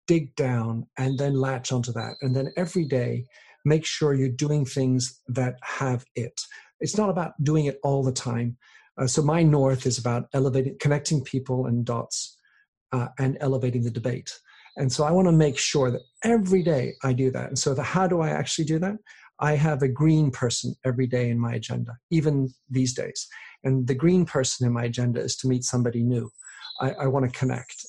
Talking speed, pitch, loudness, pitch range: 205 wpm, 130 Hz, -25 LUFS, 125-150 Hz